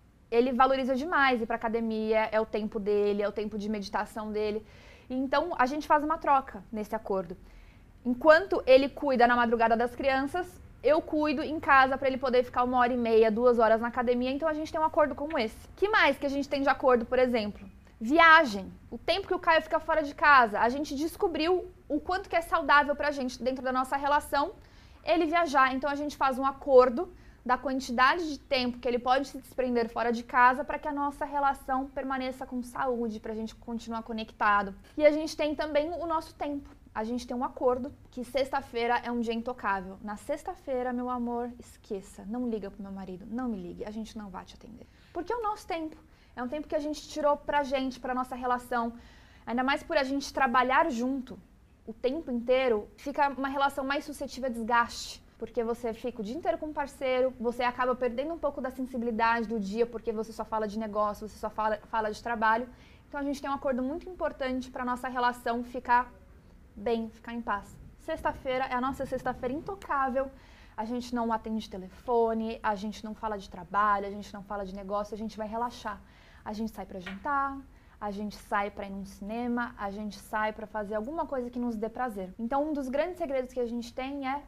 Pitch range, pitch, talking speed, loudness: 225-285 Hz, 255 Hz, 215 wpm, -29 LUFS